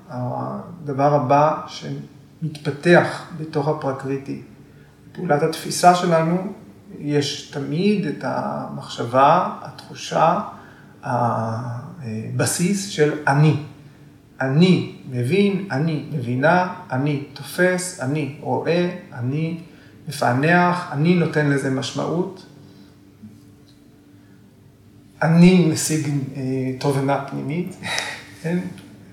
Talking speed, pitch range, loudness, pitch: 70 wpm, 130-165 Hz, -20 LUFS, 145 Hz